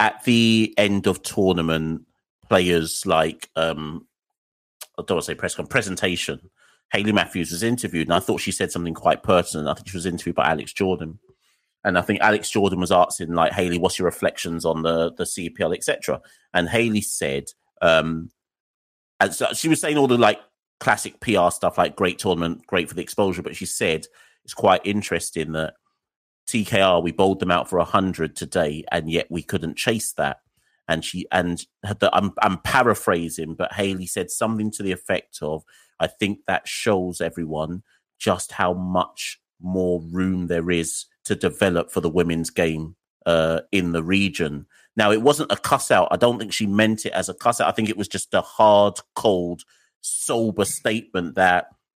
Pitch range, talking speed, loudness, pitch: 85-100 Hz, 185 wpm, -22 LUFS, 90 Hz